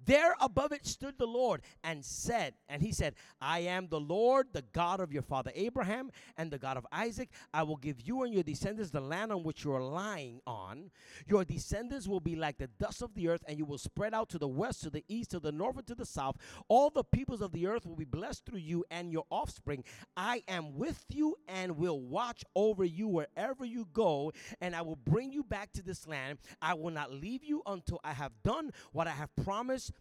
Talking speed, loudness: 235 wpm, -36 LUFS